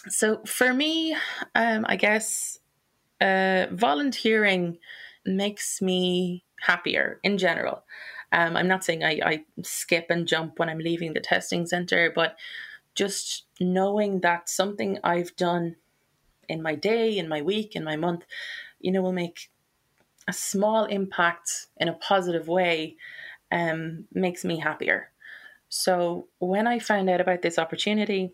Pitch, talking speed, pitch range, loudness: 185 Hz, 140 wpm, 170-215 Hz, -25 LUFS